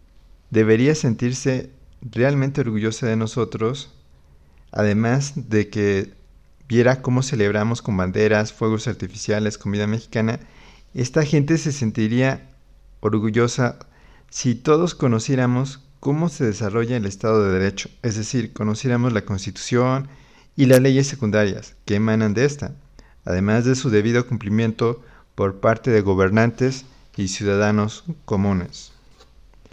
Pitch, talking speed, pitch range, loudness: 110 Hz, 115 wpm, 105-130 Hz, -21 LUFS